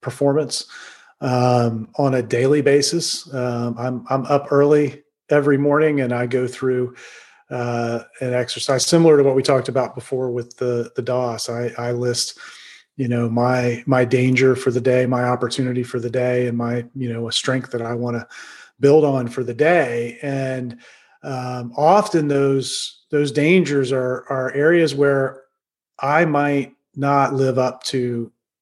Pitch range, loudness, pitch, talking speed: 125-140 Hz, -19 LUFS, 130 Hz, 165 wpm